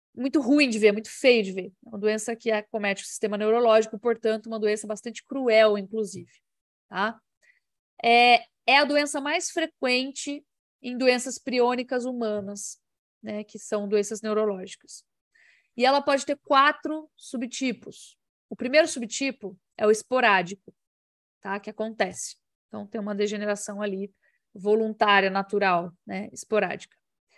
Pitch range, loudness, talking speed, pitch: 210-255 Hz, -24 LUFS, 135 wpm, 220 Hz